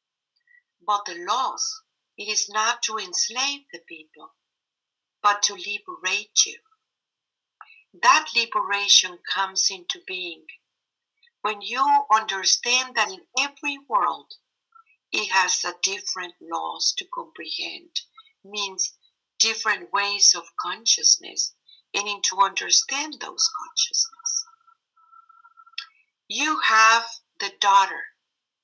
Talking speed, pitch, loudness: 100 wpm, 265 Hz, -22 LUFS